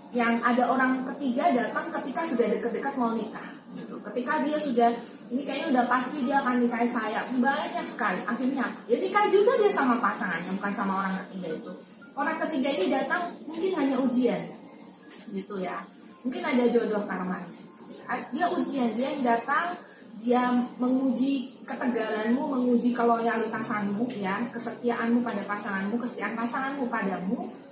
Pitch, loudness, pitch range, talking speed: 245 Hz, -27 LUFS, 230-270 Hz, 145 wpm